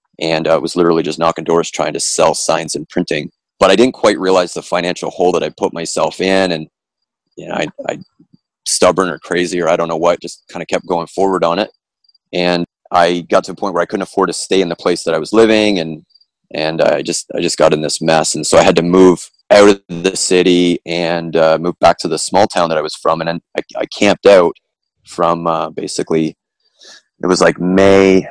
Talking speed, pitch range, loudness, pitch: 235 wpm, 85-95 Hz, -14 LUFS, 85 Hz